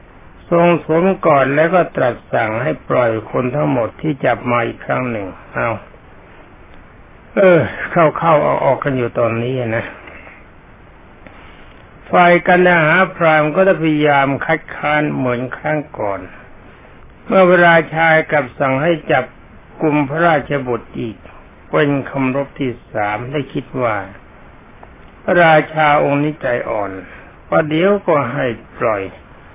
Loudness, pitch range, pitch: -15 LUFS, 125-165 Hz, 150 Hz